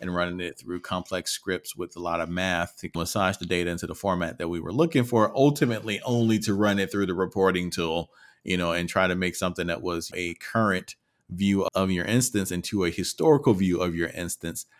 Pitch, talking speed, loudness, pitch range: 90 Hz, 220 wpm, -26 LUFS, 85-100 Hz